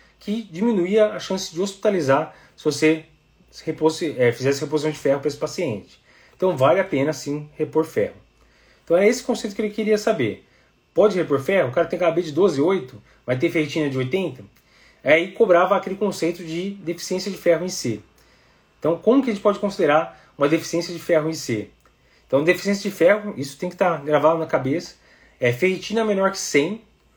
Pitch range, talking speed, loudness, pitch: 150-195 Hz, 195 wpm, -21 LUFS, 170 Hz